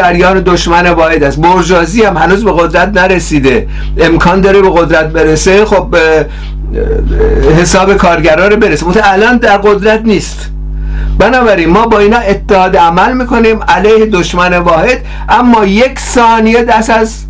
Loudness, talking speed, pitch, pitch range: -7 LUFS, 140 wpm, 185 Hz, 170-215 Hz